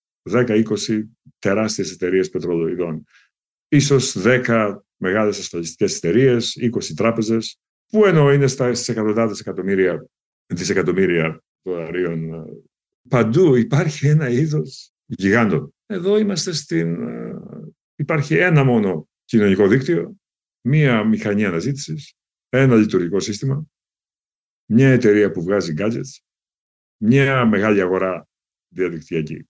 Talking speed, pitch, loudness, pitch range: 95 wpm, 115 Hz, -18 LUFS, 100-135 Hz